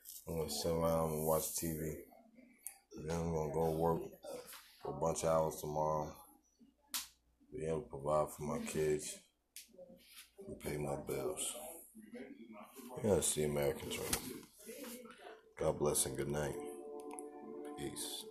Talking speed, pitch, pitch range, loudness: 130 wpm, 80 Hz, 75-85 Hz, -39 LUFS